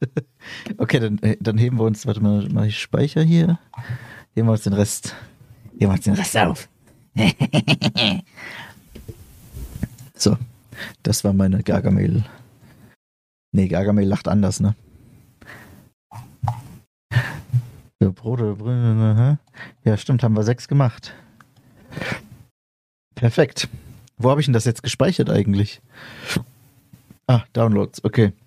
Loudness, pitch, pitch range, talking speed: -20 LUFS, 115 Hz, 105-125 Hz, 105 wpm